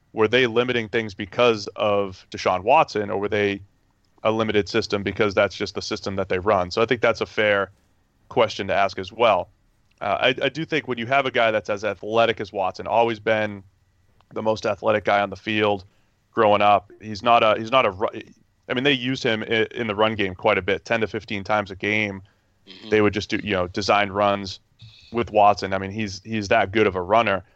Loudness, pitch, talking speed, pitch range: -22 LUFS, 105 Hz, 220 wpm, 100-115 Hz